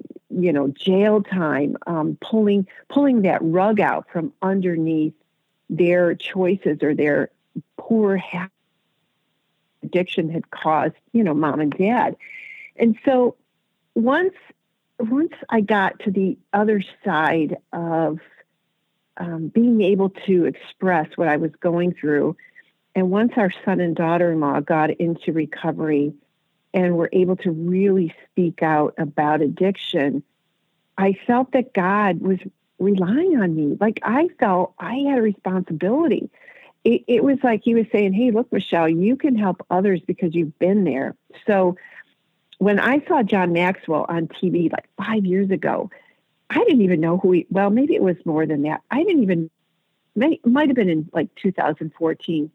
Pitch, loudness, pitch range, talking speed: 185 Hz, -20 LUFS, 165-215 Hz, 150 wpm